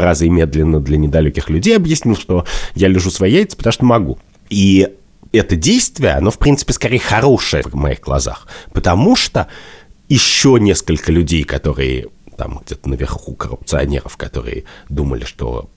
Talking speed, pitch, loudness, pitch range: 150 wpm, 85 Hz, -14 LUFS, 70-115 Hz